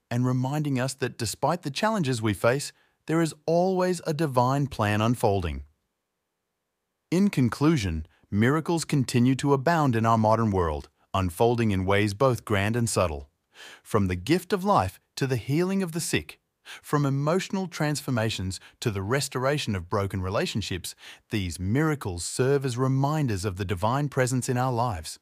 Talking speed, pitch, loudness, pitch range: 155 wpm, 125 Hz, -26 LUFS, 105-150 Hz